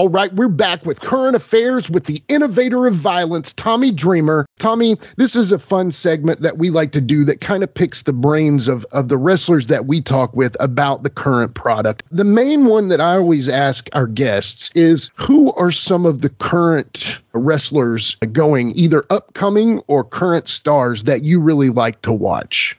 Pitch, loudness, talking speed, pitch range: 165 Hz, -15 LUFS, 190 wpm, 140-200 Hz